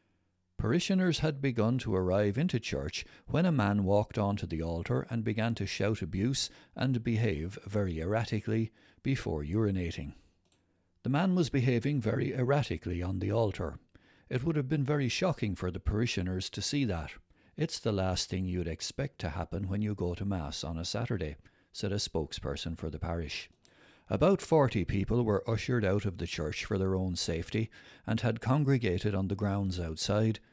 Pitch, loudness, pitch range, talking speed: 100 Hz, -32 LUFS, 90-120 Hz, 175 wpm